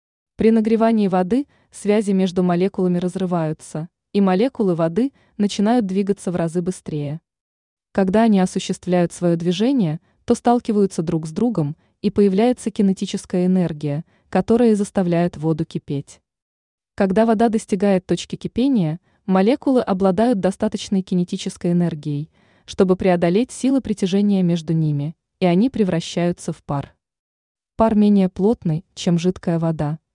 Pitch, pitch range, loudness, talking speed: 190 Hz, 170-215 Hz, -19 LUFS, 120 wpm